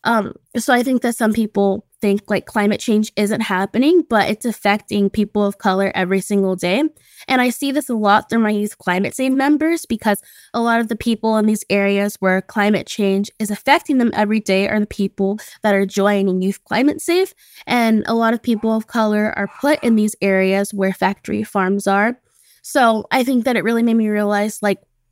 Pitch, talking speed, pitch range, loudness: 215 Hz, 205 wpm, 200-235 Hz, -18 LUFS